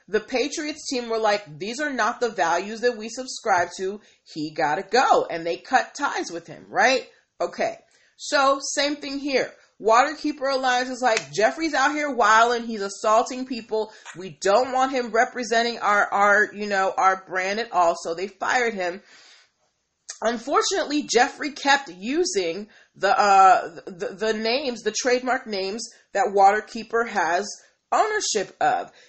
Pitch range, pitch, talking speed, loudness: 195-270 Hz, 230 Hz, 155 wpm, -22 LUFS